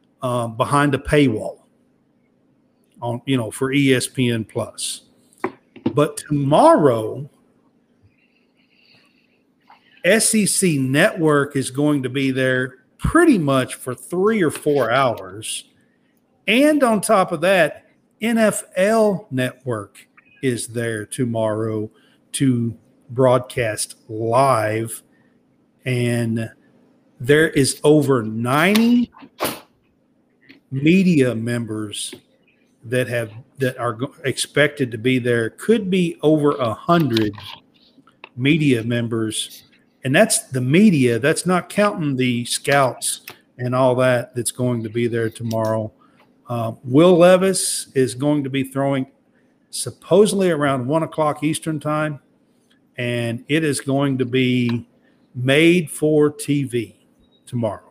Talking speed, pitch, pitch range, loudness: 105 wpm, 135 Hz, 120-165 Hz, -19 LUFS